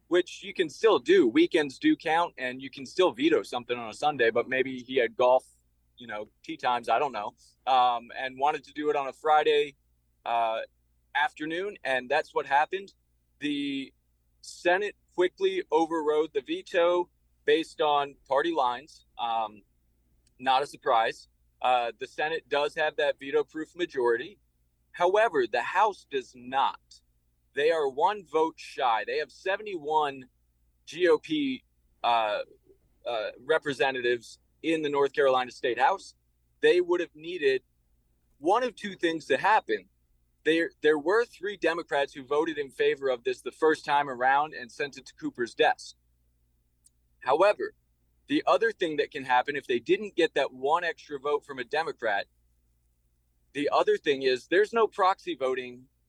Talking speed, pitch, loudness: 155 wpm, 145 Hz, -28 LUFS